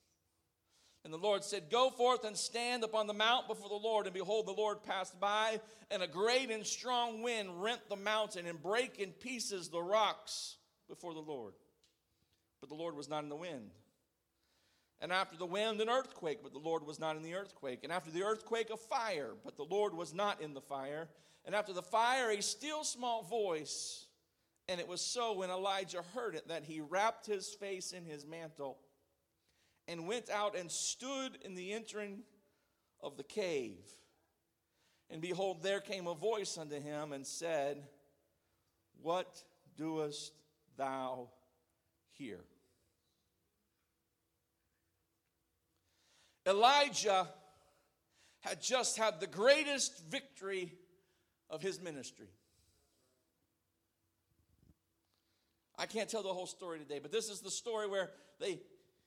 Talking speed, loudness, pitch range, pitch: 150 wpm, -38 LUFS, 145-215 Hz, 185 Hz